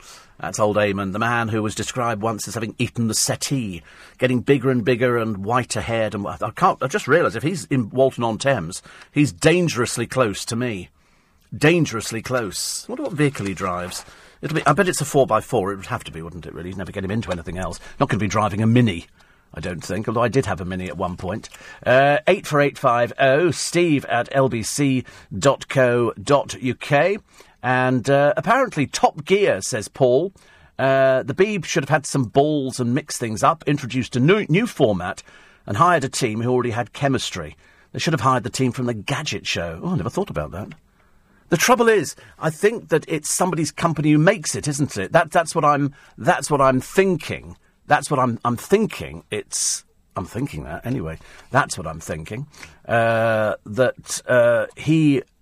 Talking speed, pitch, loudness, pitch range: 195 wpm, 125 Hz, -20 LUFS, 110-145 Hz